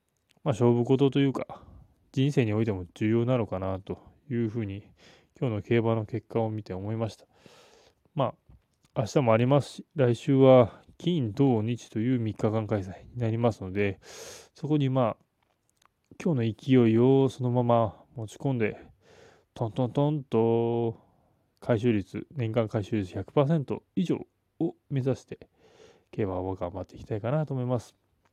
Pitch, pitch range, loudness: 115 Hz, 105-130 Hz, -27 LUFS